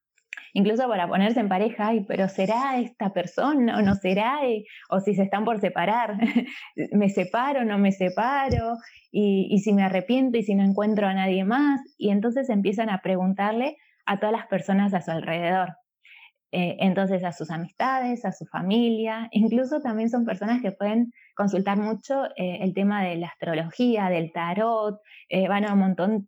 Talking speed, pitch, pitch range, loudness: 180 wpm, 205 Hz, 190-230 Hz, -24 LUFS